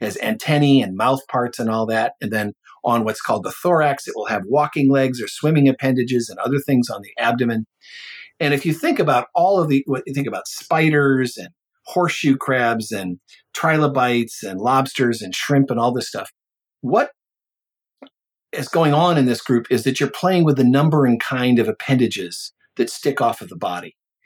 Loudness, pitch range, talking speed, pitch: -19 LUFS, 120-145 Hz, 195 wpm, 130 Hz